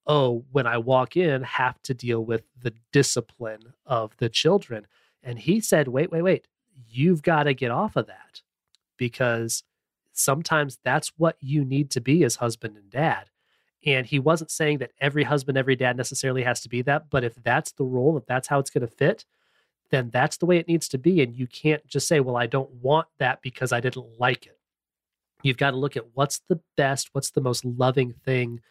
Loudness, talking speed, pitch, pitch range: -24 LUFS, 210 wpm, 135 Hz, 125-150 Hz